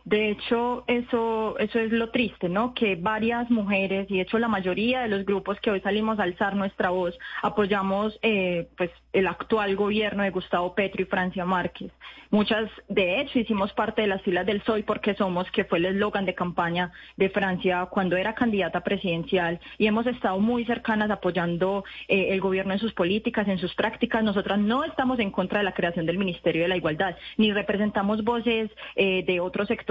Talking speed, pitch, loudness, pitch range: 195 wpm, 205 Hz, -25 LUFS, 185-220 Hz